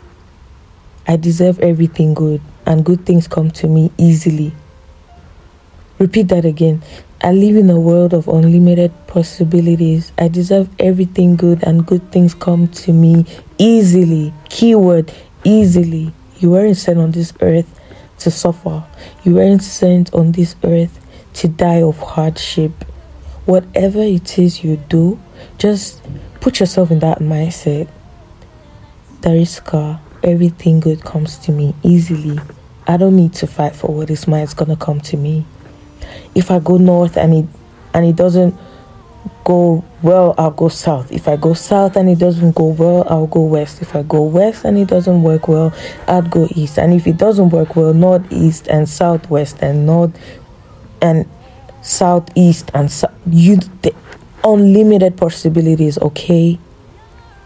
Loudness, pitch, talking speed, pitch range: -12 LUFS, 165 Hz, 155 wpm, 155-175 Hz